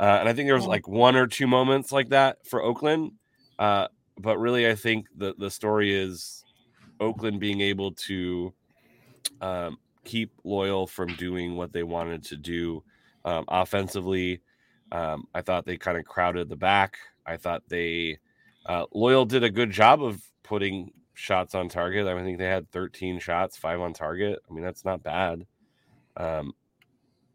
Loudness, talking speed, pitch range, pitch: -26 LUFS, 175 wpm, 90-110 Hz, 95 Hz